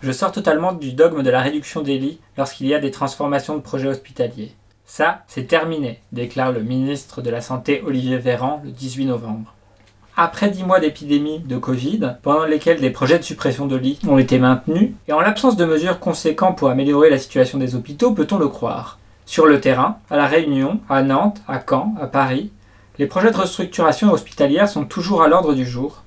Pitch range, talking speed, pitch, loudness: 130-165 Hz, 205 wpm, 140 Hz, -18 LUFS